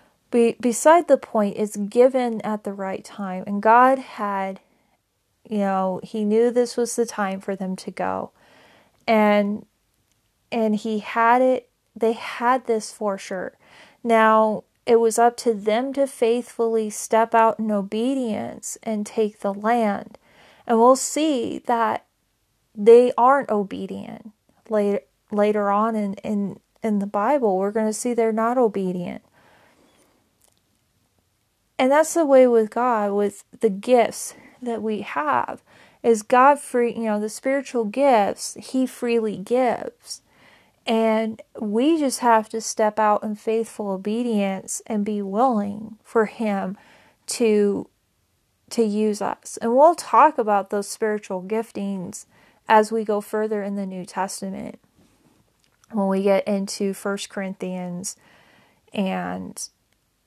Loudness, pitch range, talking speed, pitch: -21 LUFS, 200-235 Hz, 135 wpm, 220 Hz